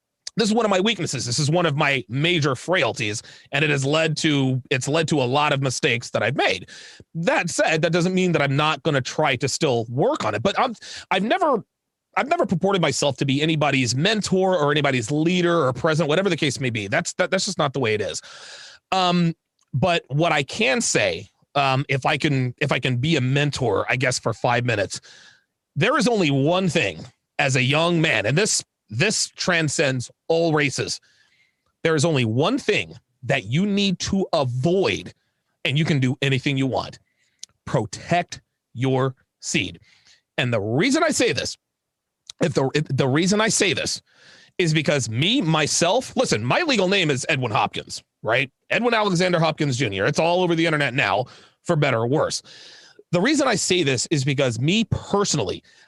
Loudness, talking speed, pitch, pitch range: -21 LUFS, 190 wpm, 155 Hz, 135-175 Hz